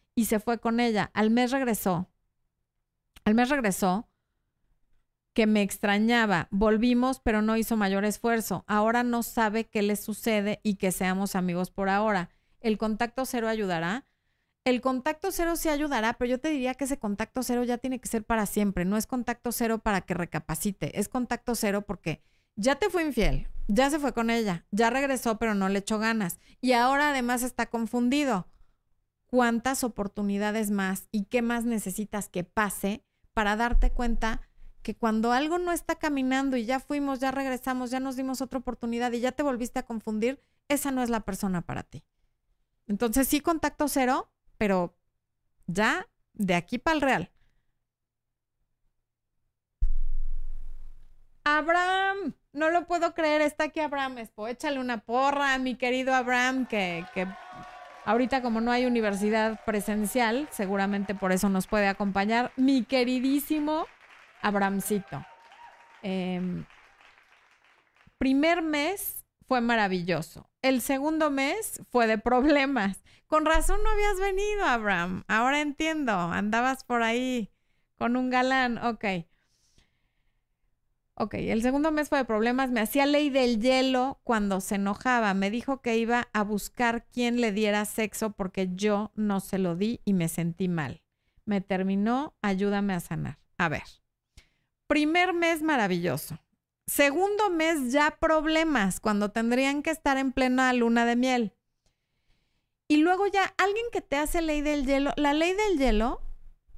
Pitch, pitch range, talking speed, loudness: 235 Hz, 205-270 Hz, 150 wpm, -27 LUFS